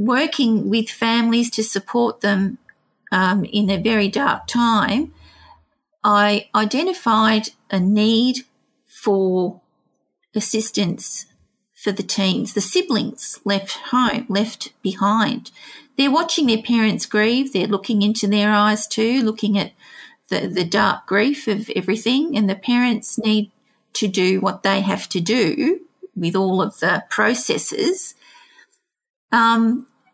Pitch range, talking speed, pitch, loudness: 200-250 Hz, 125 wpm, 220 Hz, -19 LUFS